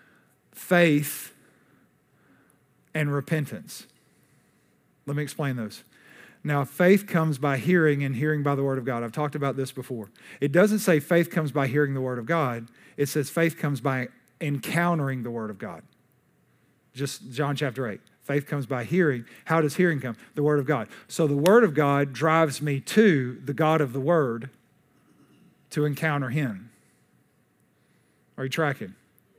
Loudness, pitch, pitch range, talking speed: -25 LUFS, 145 Hz, 130-155 Hz, 165 wpm